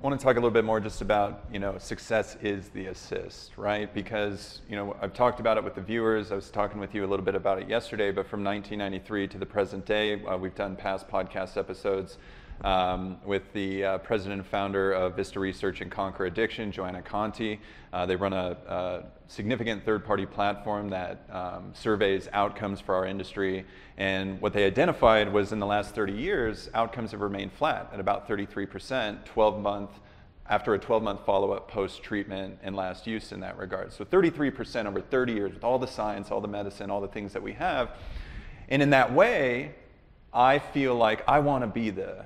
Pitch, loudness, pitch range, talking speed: 100 Hz, -29 LUFS, 95-110 Hz, 205 wpm